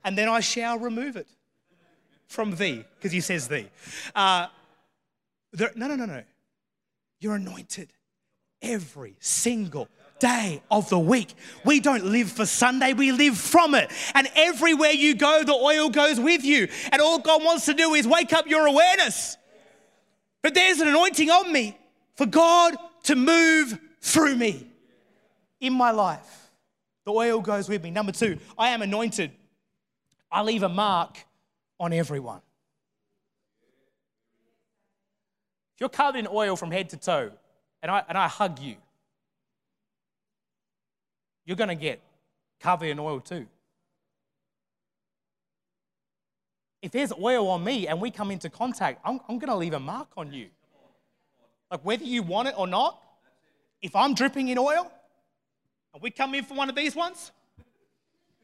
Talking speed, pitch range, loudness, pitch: 150 wpm, 195-285 Hz, -23 LUFS, 230 Hz